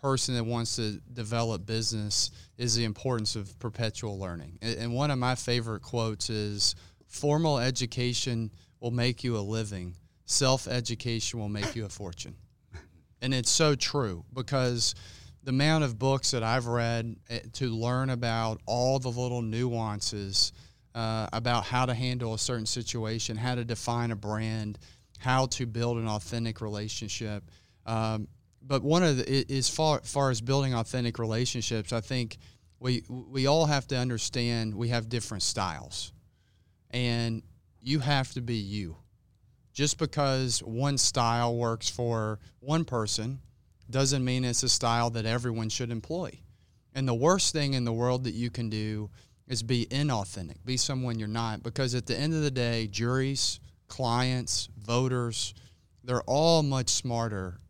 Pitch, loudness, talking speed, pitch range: 115 Hz, -29 LUFS, 155 wpm, 110-125 Hz